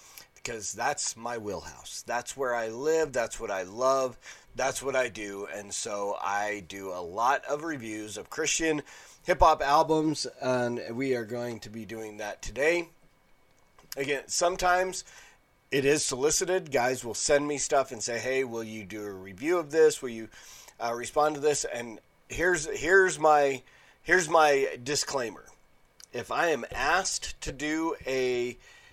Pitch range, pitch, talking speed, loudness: 115-155 Hz, 130 Hz, 160 wpm, -28 LUFS